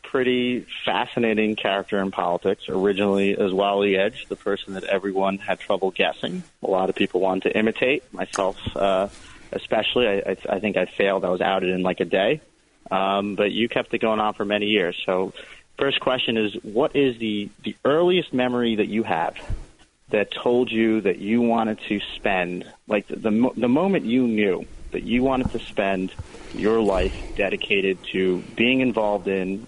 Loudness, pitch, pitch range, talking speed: -23 LUFS, 105 Hz, 95-115 Hz, 180 wpm